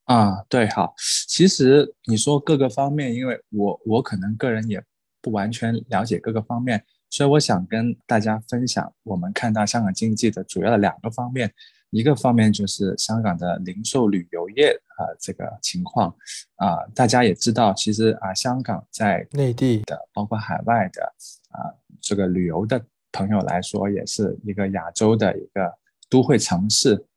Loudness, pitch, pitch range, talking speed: -21 LUFS, 110 Hz, 100-130 Hz, 265 characters per minute